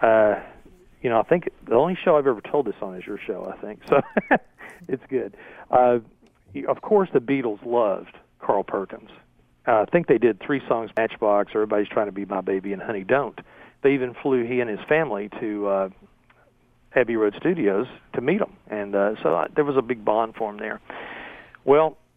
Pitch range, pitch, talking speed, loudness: 100-130 Hz, 110 Hz, 200 wpm, -23 LUFS